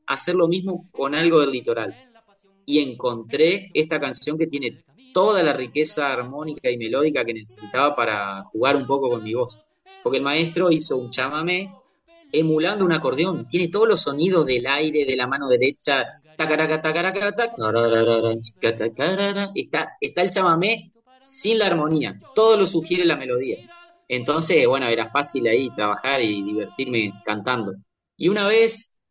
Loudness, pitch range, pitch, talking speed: -21 LUFS, 125-190 Hz, 155 Hz, 145 wpm